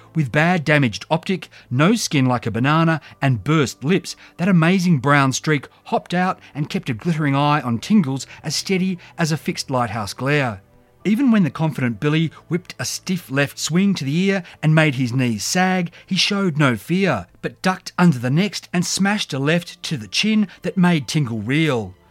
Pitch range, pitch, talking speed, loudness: 130-180 Hz, 155 Hz, 190 wpm, -19 LUFS